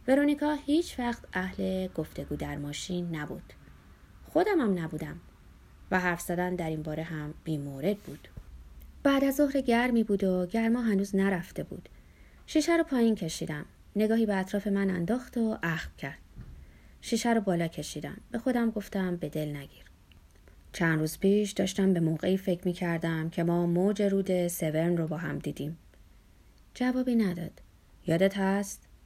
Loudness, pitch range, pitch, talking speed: -30 LUFS, 160-220 Hz, 185 Hz, 155 wpm